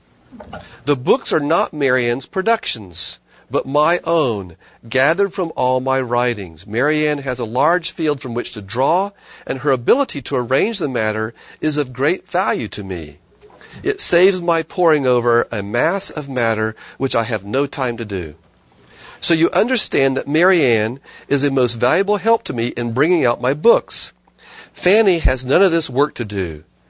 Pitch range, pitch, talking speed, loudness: 115-165 Hz, 130 Hz, 170 wpm, -17 LUFS